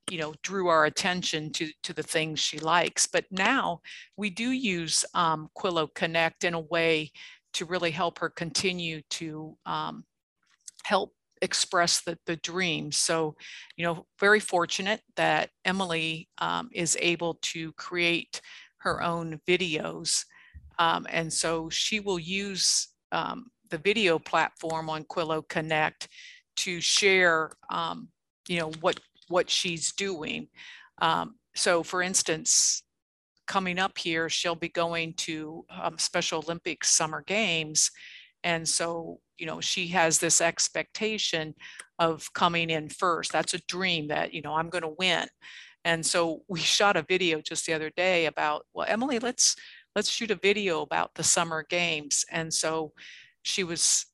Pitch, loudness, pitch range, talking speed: 170 Hz, -27 LUFS, 160-190 Hz, 150 wpm